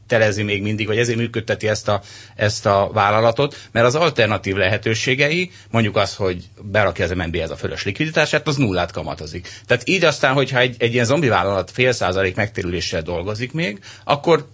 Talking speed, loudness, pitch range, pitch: 175 wpm, -19 LUFS, 100-125 Hz, 110 Hz